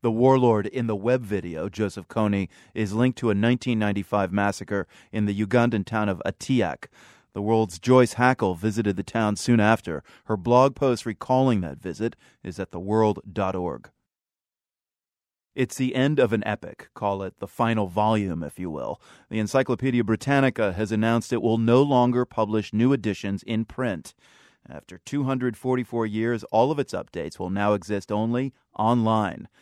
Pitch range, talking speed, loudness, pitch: 100-120 Hz, 160 wpm, -24 LUFS, 110 Hz